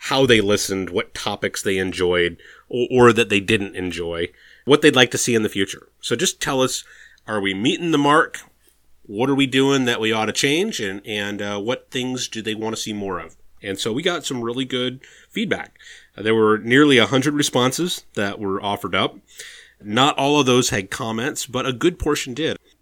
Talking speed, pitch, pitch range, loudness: 215 wpm, 110 Hz, 100-130 Hz, -20 LUFS